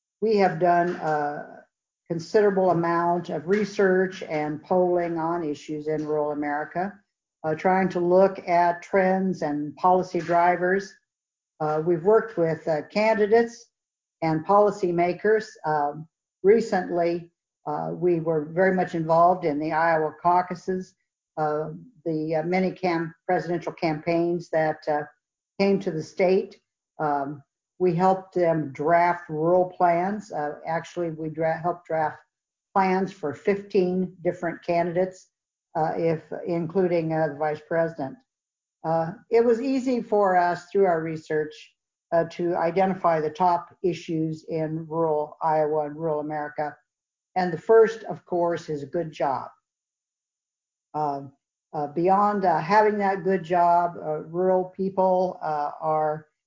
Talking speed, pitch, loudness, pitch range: 135 wpm, 170 Hz, -24 LUFS, 155-185 Hz